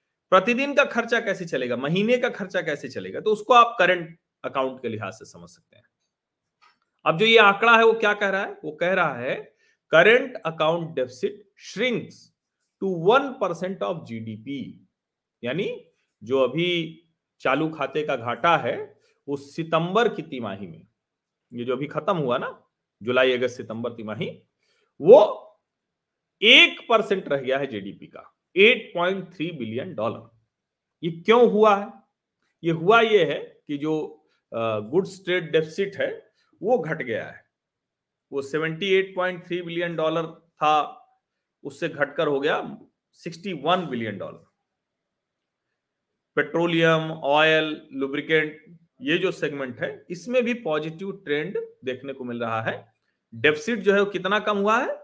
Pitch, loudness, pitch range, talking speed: 170 Hz, -22 LUFS, 145-210 Hz, 130 wpm